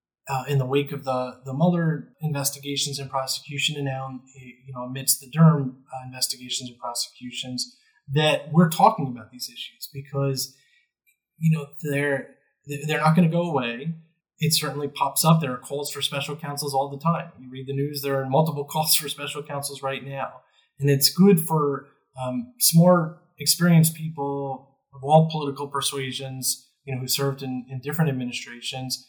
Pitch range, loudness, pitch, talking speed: 130-155 Hz, -24 LUFS, 140 Hz, 175 wpm